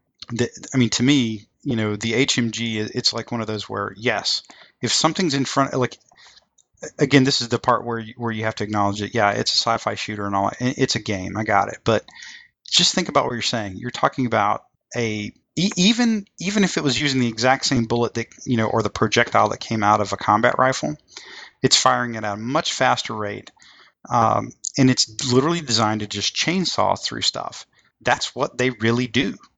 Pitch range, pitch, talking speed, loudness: 105-130 Hz, 120 Hz, 205 wpm, -20 LUFS